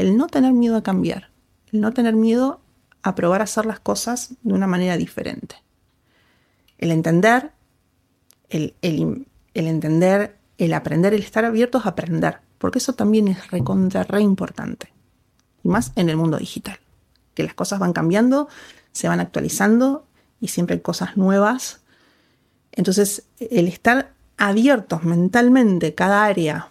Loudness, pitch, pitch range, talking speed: -19 LUFS, 205 Hz, 175-235 Hz, 150 wpm